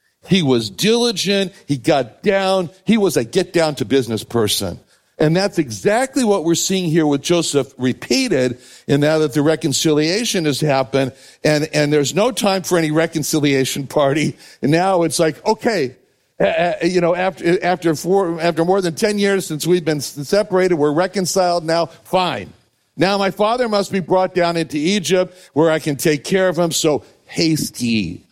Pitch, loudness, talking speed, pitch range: 165 Hz, -17 LUFS, 175 wpm, 145-185 Hz